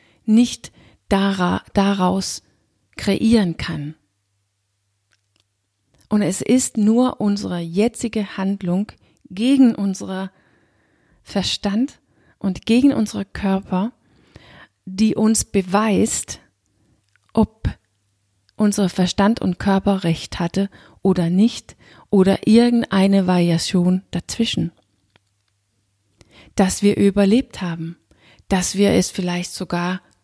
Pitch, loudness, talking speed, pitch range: 190 Hz, -19 LUFS, 85 wpm, 135-205 Hz